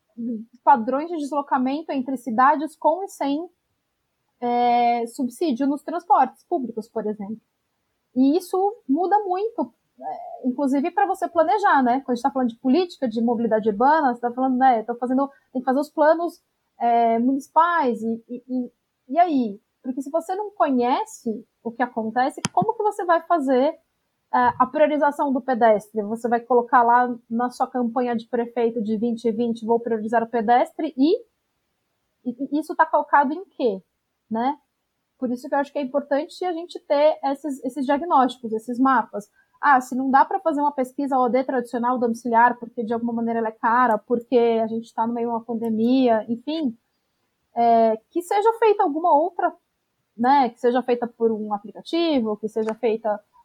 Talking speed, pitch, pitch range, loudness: 170 wpm, 260 Hz, 235-310 Hz, -22 LUFS